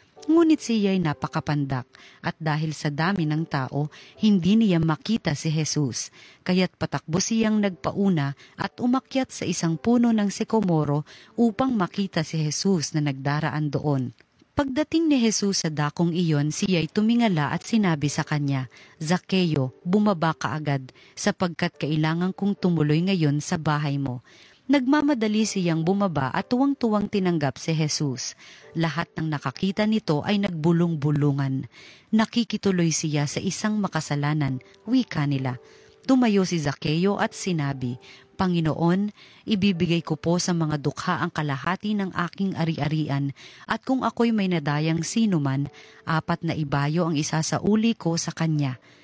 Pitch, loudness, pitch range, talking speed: 165 Hz, -24 LUFS, 150-200 Hz, 130 wpm